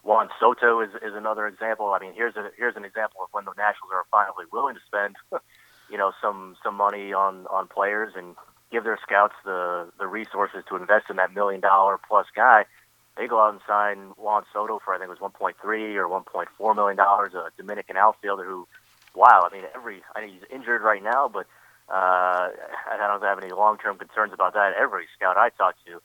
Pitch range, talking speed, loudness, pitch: 95-105 Hz, 220 wpm, -23 LUFS, 100 Hz